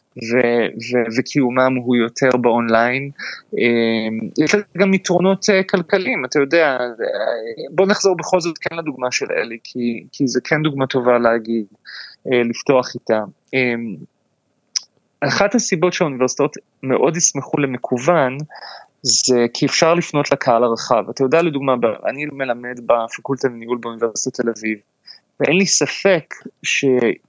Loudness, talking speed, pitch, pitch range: -18 LUFS, 120 wpm, 130 Hz, 120-165 Hz